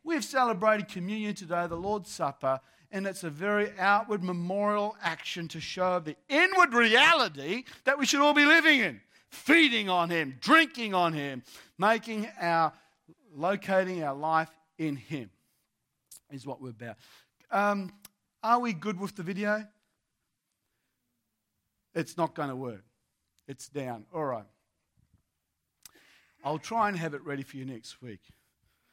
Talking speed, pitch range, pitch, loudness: 145 wpm, 135-210 Hz, 175 Hz, -27 LUFS